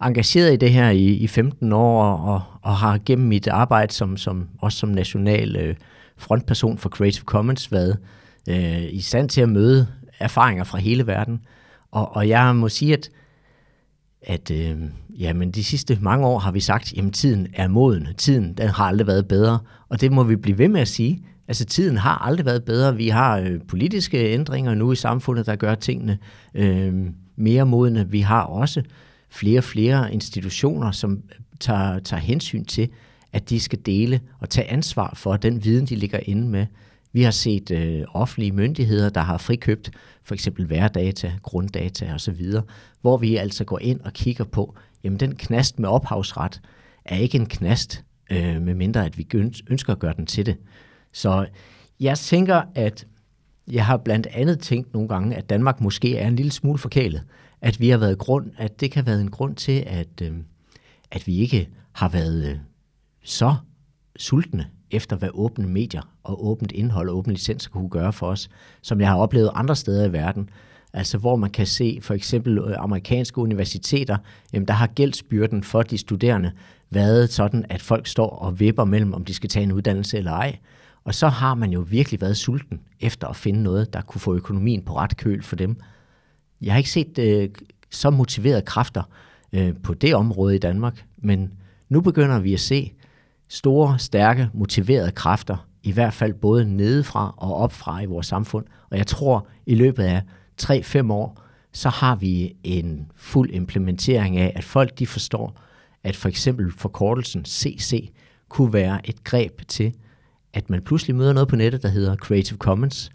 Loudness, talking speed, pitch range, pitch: -21 LUFS, 180 wpm, 100-125 Hz, 110 Hz